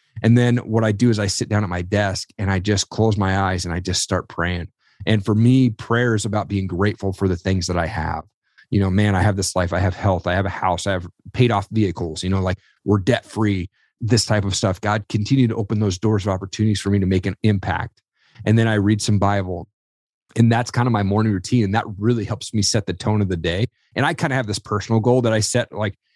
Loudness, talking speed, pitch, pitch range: -20 LUFS, 265 wpm, 105 Hz, 95-115 Hz